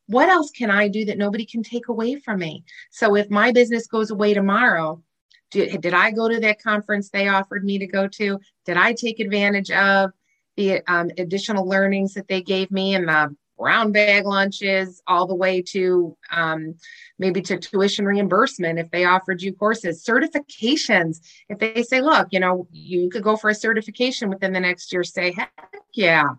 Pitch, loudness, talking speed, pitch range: 200 Hz, -20 LUFS, 190 wpm, 185-220 Hz